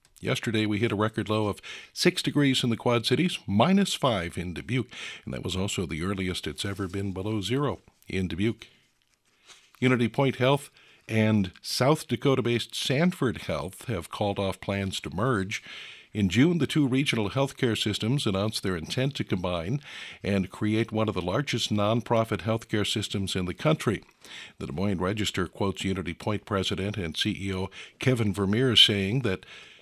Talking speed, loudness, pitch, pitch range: 170 wpm, -27 LUFS, 110 Hz, 95-125 Hz